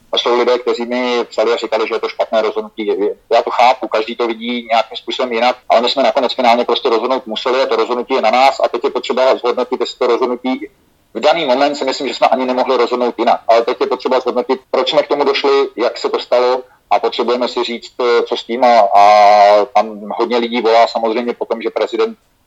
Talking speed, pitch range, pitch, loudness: 225 wpm, 115-130 Hz, 120 Hz, -14 LUFS